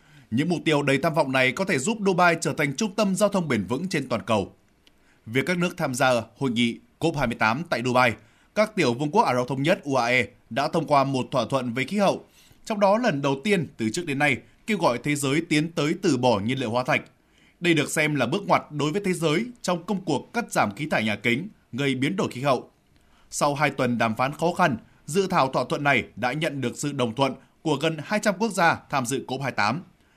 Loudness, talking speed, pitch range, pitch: -24 LUFS, 240 wpm, 125-170 Hz, 145 Hz